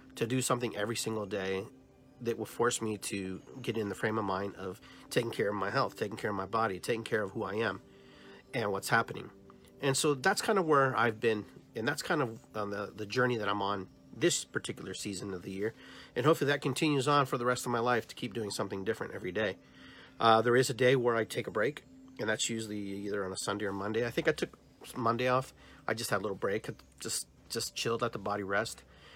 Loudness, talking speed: -33 LUFS, 245 wpm